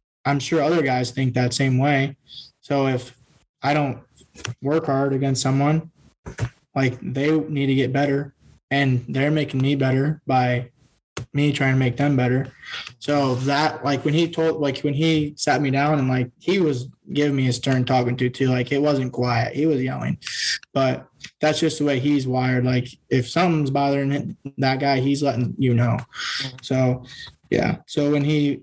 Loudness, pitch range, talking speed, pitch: -22 LUFS, 130-145 Hz, 180 wpm, 140 Hz